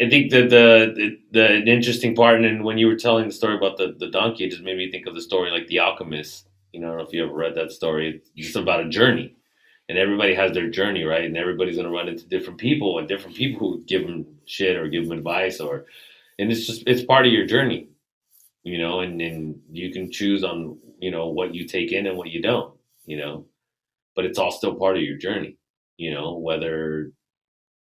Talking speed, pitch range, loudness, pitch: 240 wpm, 80-115 Hz, -21 LUFS, 95 Hz